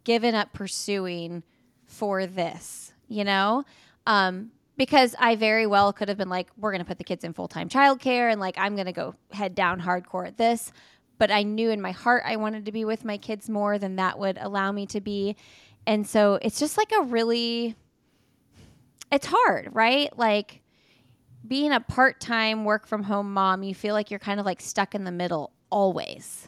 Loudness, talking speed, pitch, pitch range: -25 LUFS, 190 wpm, 205 Hz, 185-225 Hz